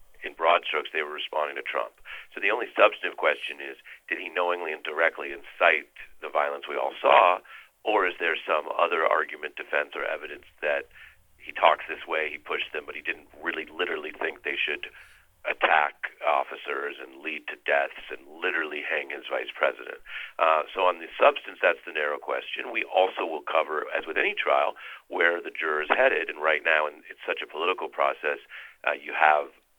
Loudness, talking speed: -26 LUFS, 195 wpm